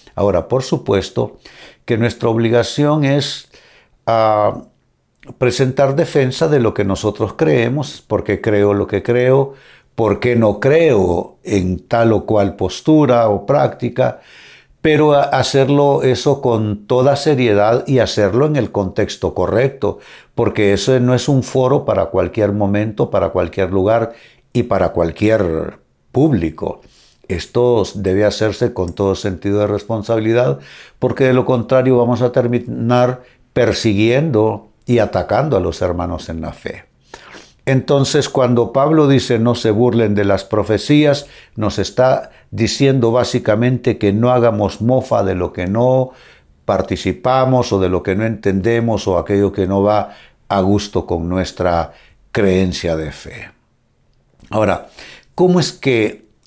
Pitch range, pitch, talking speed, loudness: 100-130 Hz, 115 Hz, 135 wpm, -15 LUFS